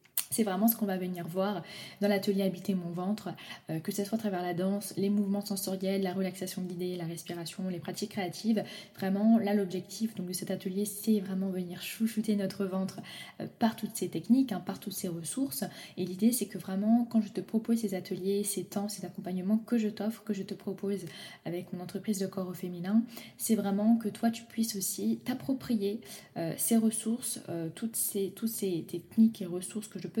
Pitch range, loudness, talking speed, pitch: 185-220 Hz, -32 LUFS, 210 wpm, 200 Hz